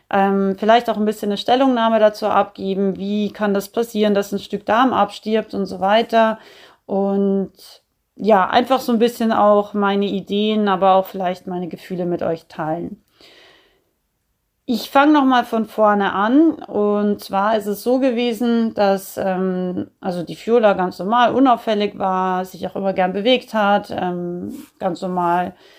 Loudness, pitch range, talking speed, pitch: -18 LUFS, 190-225 Hz, 160 wpm, 205 Hz